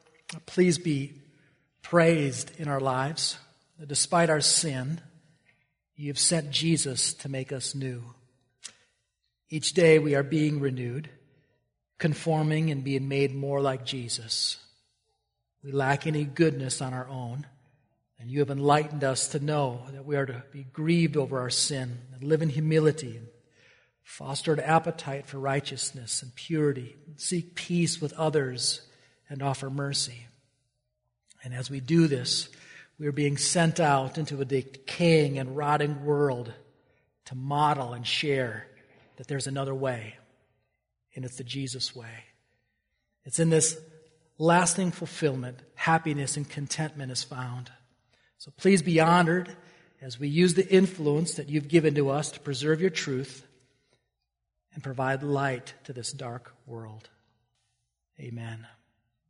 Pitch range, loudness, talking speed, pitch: 130-155 Hz, -27 LUFS, 140 wpm, 140 Hz